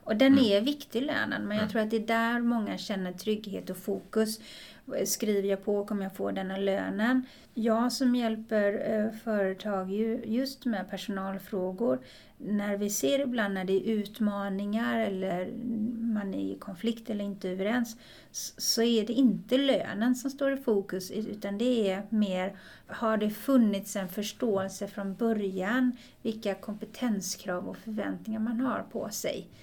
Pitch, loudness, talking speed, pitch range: 215 Hz, -30 LUFS, 155 wpm, 200-235 Hz